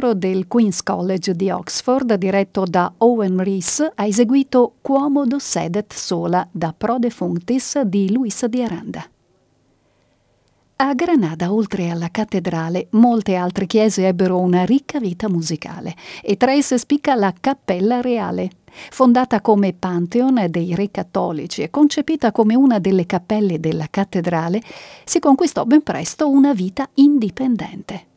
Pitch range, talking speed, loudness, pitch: 185-255 Hz, 135 wpm, -18 LUFS, 210 Hz